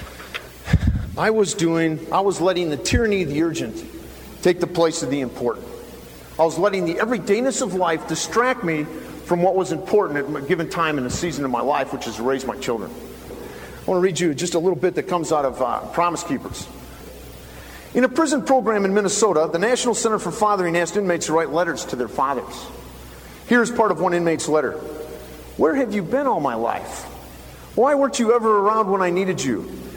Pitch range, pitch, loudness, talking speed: 155-210 Hz, 175 Hz, -21 LUFS, 210 wpm